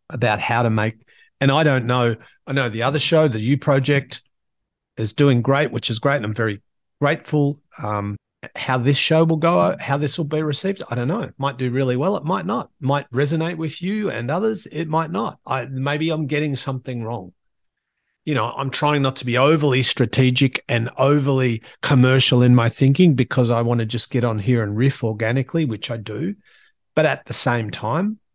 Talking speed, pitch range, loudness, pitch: 205 wpm, 120-150 Hz, -20 LUFS, 135 Hz